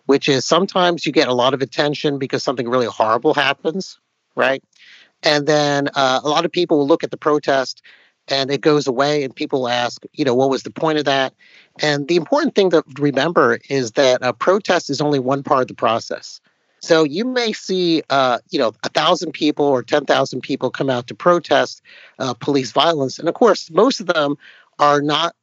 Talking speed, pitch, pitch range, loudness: 205 wpm, 145 Hz, 135-165 Hz, -18 LUFS